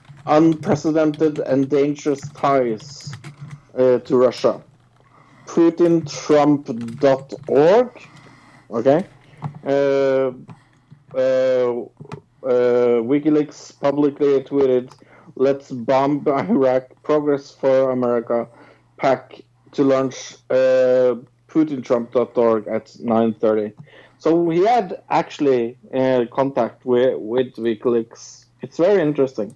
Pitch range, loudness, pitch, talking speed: 125-145 Hz, -19 LUFS, 135 Hz, 80 wpm